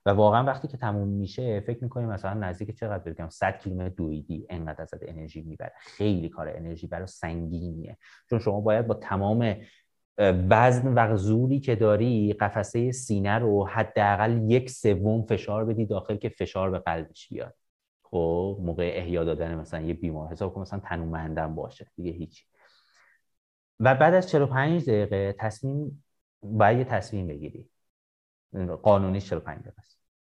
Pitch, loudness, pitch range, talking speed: 100 Hz, -26 LUFS, 85-115 Hz, 145 wpm